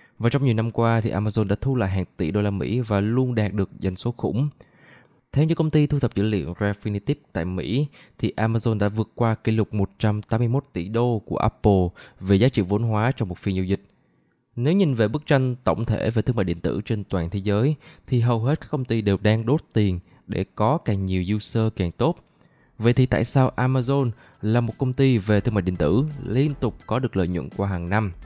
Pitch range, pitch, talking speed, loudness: 100-130 Hz, 110 Hz, 235 wpm, -23 LUFS